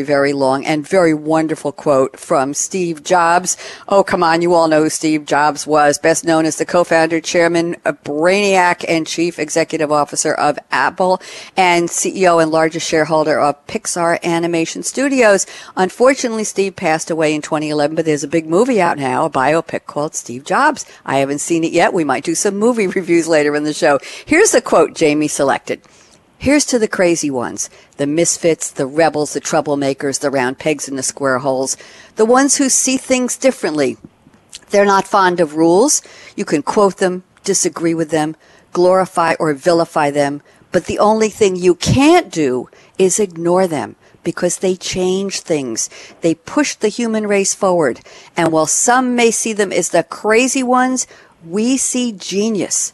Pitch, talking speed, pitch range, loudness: 170 Hz, 175 wpm, 155-195 Hz, -15 LUFS